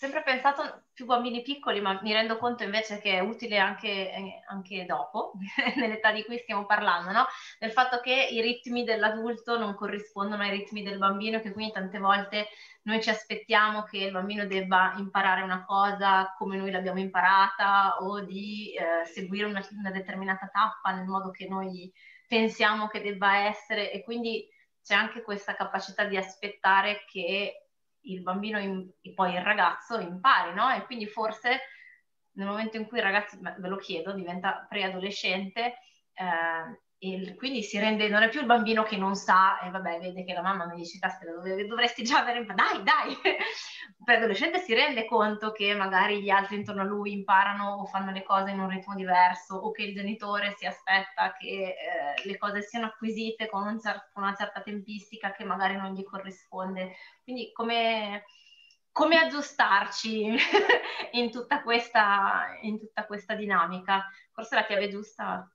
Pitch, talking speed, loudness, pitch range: 205 Hz, 175 wpm, -28 LUFS, 195-225 Hz